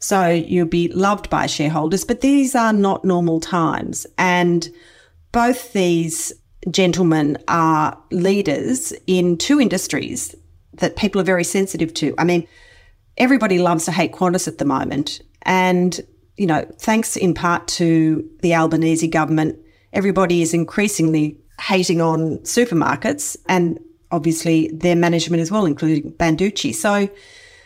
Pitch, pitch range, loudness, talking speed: 175 Hz, 160-195 Hz, -18 LUFS, 135 wpm